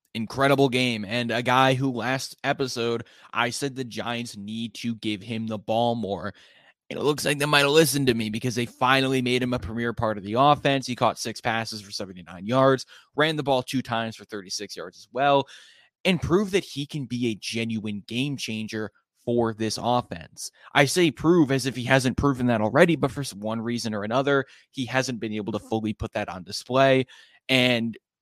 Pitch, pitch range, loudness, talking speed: 120 Hz, 110-135 Hz, -24 LUFS, 205 wpm